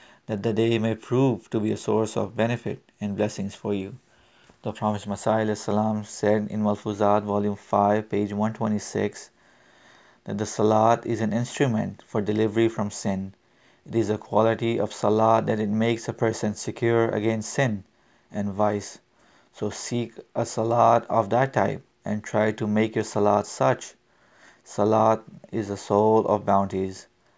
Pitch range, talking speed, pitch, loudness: 105-115 Hz, 155 wpm, 110 Hz, -25 LUFS